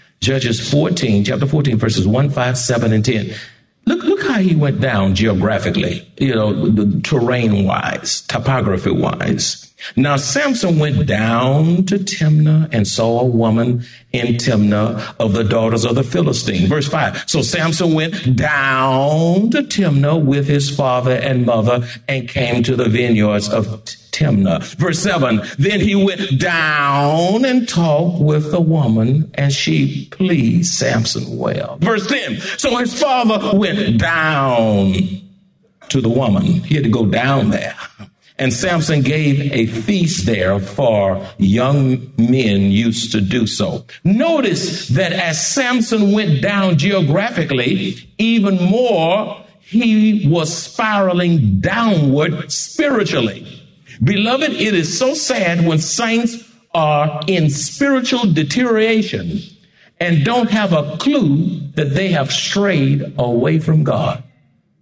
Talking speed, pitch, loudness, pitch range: 135 wpm, 150 Hz, -15 LUFS, 125-190 Hz